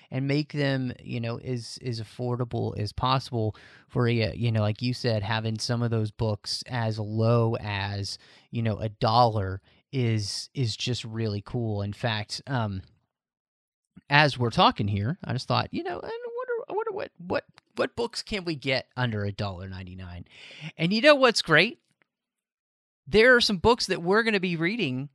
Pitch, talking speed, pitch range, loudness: 120 Hz, 185 wpm, 110-150 Hz, -26 LUFS